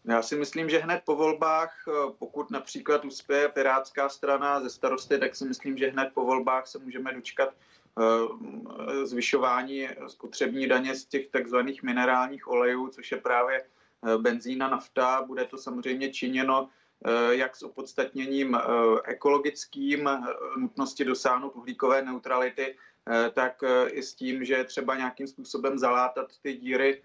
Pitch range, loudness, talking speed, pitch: 125-140 Hz, -28 LUFS, 135 wpm, 130 Hz